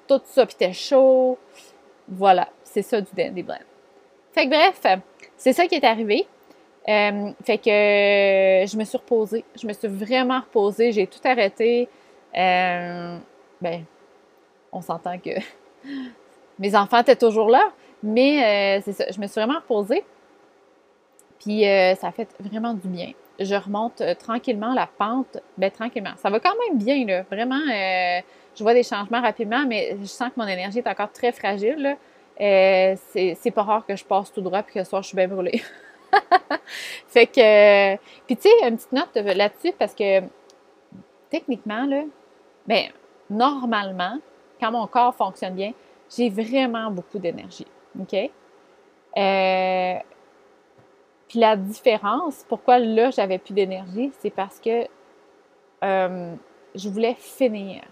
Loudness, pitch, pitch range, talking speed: -21 LUFS, 220 Hz, 195-255 Hz, 160 wpm